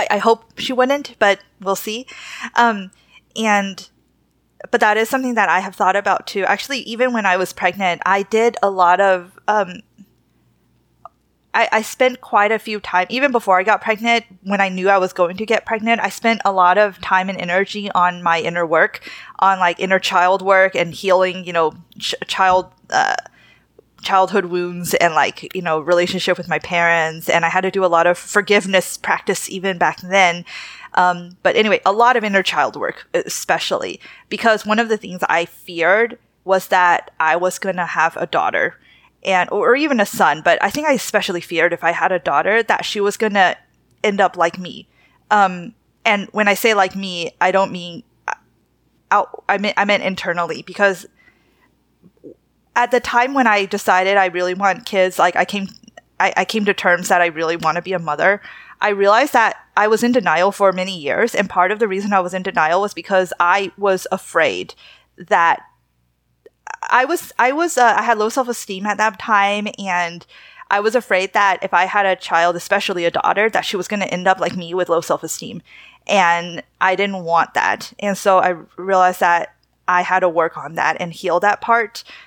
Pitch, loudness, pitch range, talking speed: 190 Hz, -17 LUFS, 180-210 Hz, 205 wpm